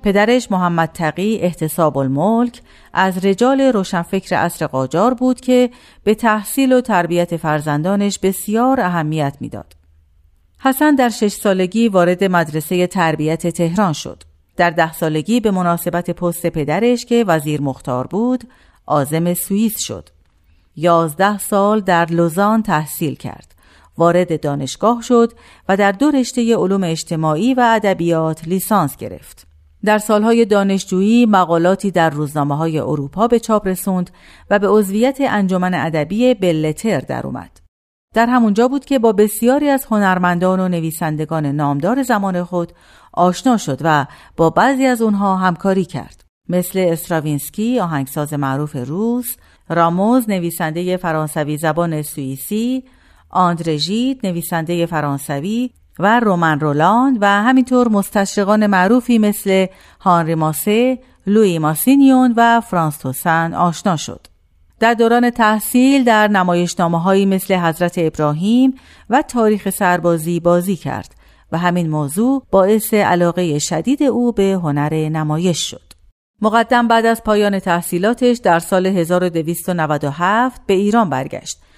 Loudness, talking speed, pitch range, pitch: -16 LUFS, 125 wpm, 160-220 Hz, 180 Hz